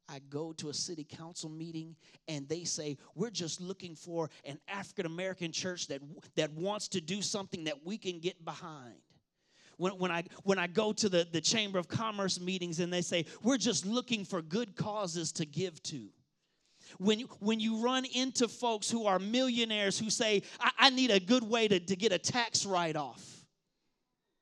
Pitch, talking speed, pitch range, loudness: 185 Hz, 195 wpm, 165-210 Hz, -33 LUFS